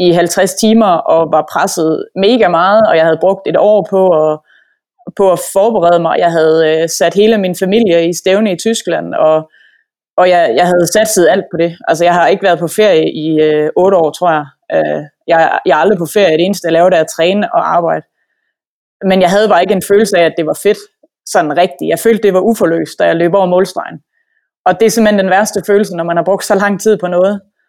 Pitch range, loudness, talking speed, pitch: 165-205 Hz, -11 LUFS, 235 wpm, 180 Hz